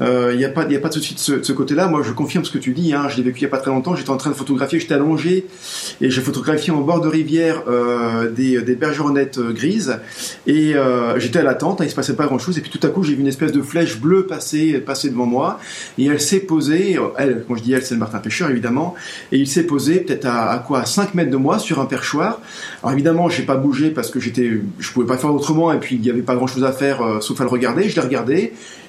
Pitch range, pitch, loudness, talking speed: 130-160 Hz, 140 Hz, -18 LUFS, 290 wpm